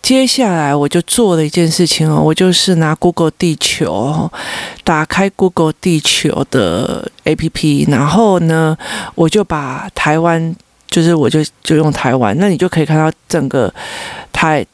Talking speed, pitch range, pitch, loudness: 260 characters per minute, 155-180 Hz, 165 Hz, -13 LUFS